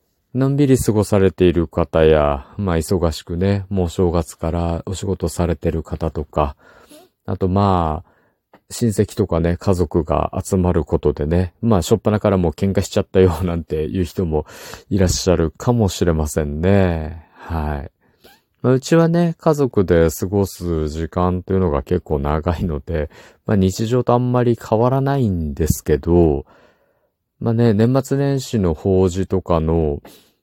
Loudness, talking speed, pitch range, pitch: -18 LUFS, 305 characters per minute, 80-105 Hz, 90 Hz